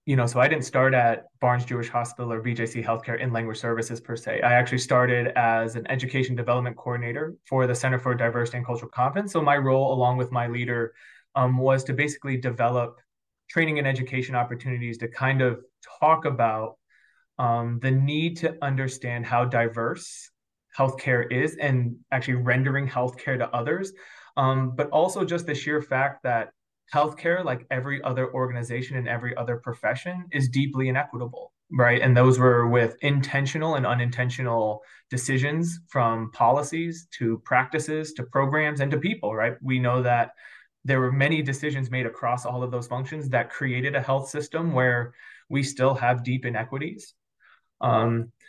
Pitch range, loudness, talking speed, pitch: 120-140 Hz, -25 LUFS, 165 wpm, 130 Hz